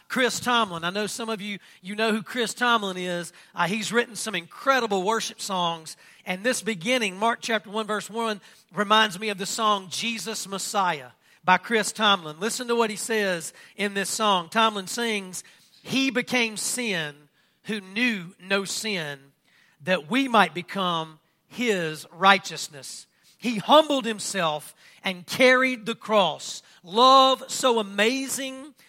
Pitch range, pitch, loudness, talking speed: 185-230 Hz, 210 Hz, -24 LUFS, 145 wpm